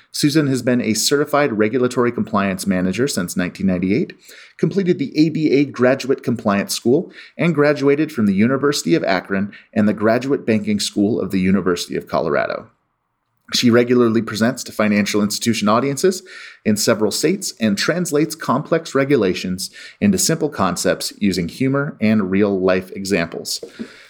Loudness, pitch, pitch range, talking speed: -18 LUFS, 120 Hz, 105-145 Hz, 140 wpm